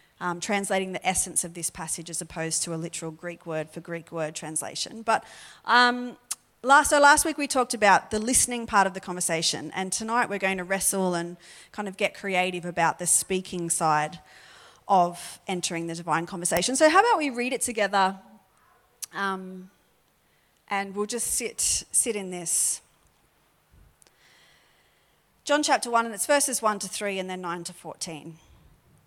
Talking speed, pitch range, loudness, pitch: 170 wpm, 170-225 Hz, -25 LUFS, 190 Hz